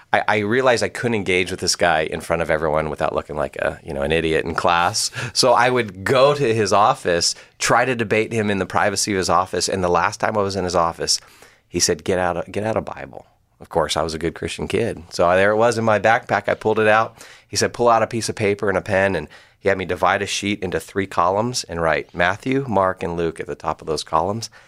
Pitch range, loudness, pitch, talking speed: 85-110 Hz, -19 LUFS, 100 Hz, 270 wpm